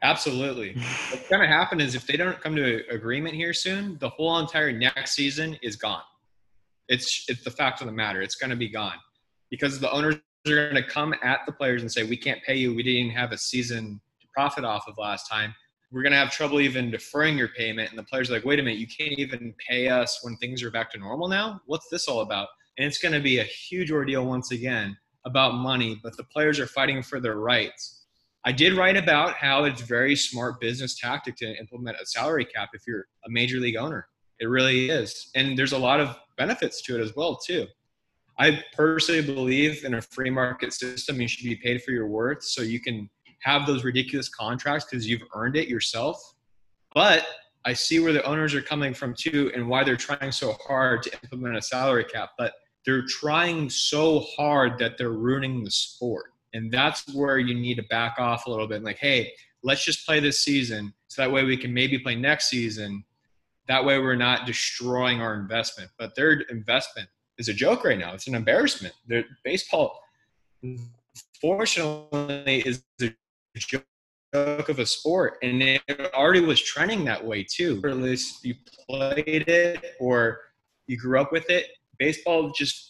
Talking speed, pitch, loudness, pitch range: 205 wpm, 130 Hz, -25 LUFS, 120-145 Hz